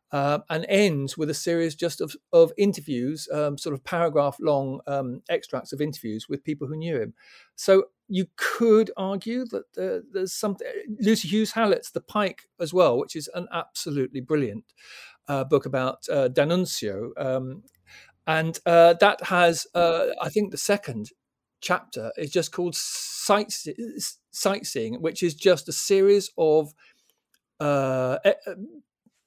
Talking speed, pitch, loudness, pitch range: 150 wpm, 170 Hz, -24 LUFS, 145-200 Hz